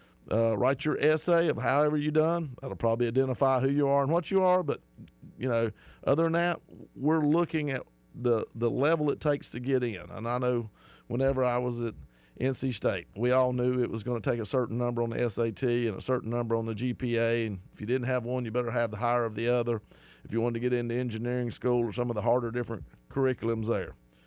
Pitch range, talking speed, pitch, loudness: 115-135 Hz, 235 wpm, 120 Hz, -29 LUFS